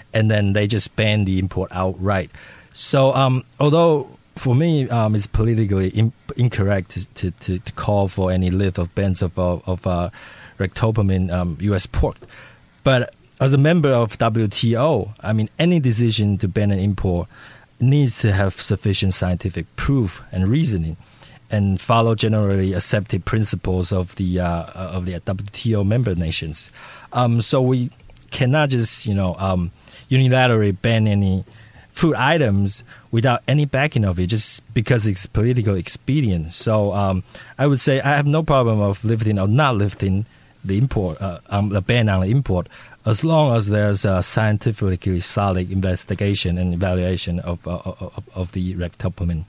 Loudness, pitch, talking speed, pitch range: -19 LUFS, 105 Hz, 160 wpm, 95-120 Hz